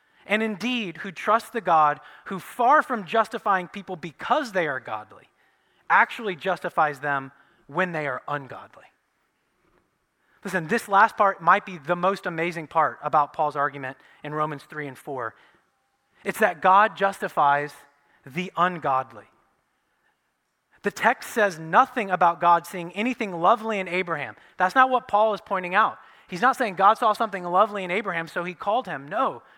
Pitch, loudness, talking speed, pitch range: 185 Hz, -23 LUFS, 160 wpm, 155-210 Hz